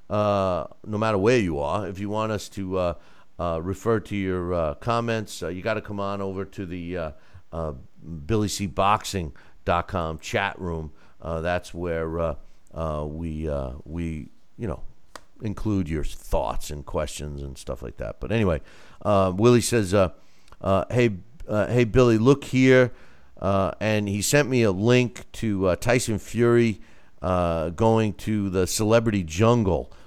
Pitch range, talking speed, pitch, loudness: 85-110 Hz, 160 wpm, 95 Hz, -24 LUFS